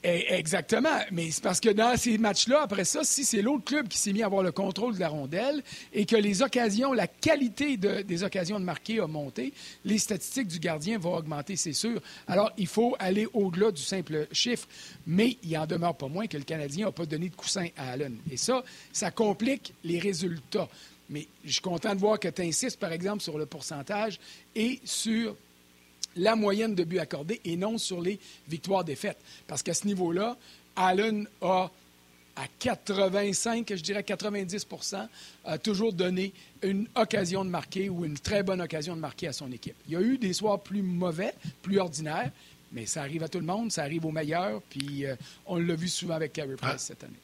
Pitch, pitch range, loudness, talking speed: 190 Hz, 165-215 Hz, -30 LUFS, 205 wpm